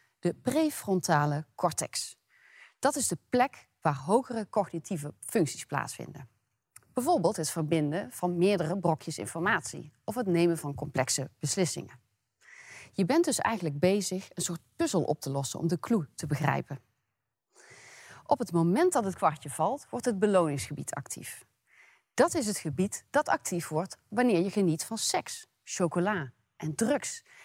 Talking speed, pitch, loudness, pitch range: 145 wpm, 175 Hz, -30 LUFS, 155-215 Hz